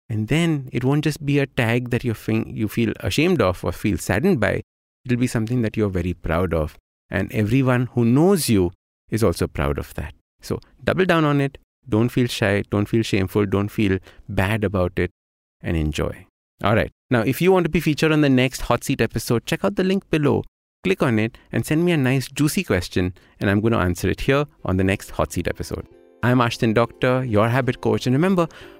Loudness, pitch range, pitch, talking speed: -21 LUFS, 95-135 Hz, 115 Hz, 220 wpm